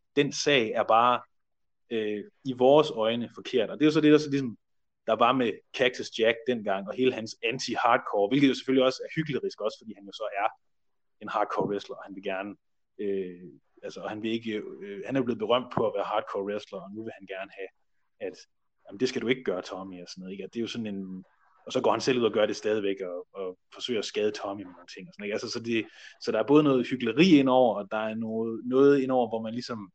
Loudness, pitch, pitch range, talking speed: -27 LUFS, 115 Hz, 100-135 Hz, 255 wpm